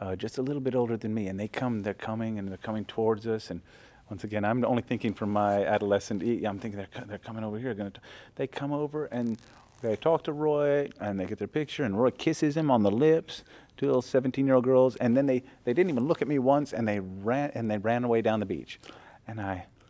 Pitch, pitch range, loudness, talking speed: 115 Hz, 105-130 Hz, -29 LUFS, 245 wpm